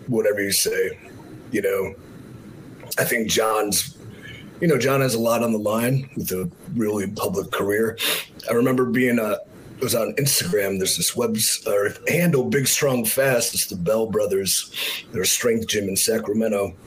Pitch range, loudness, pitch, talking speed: 105-135 Hz, -21 LUFS, 115 Hz, 175 wpm